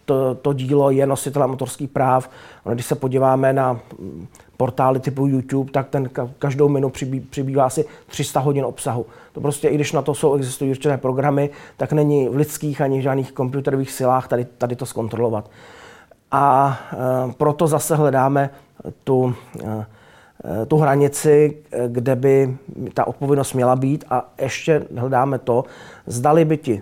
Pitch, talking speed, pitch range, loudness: 135 Hz, 150 wpm, 130-145 Hz, -19 LUFS